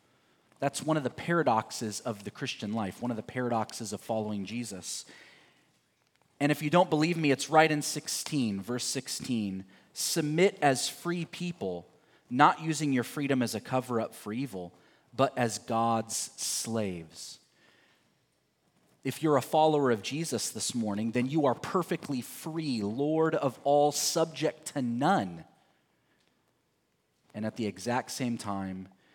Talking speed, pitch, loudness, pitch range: 145 wpm, 125 Hz, -30 LUFS, 110-150 Hz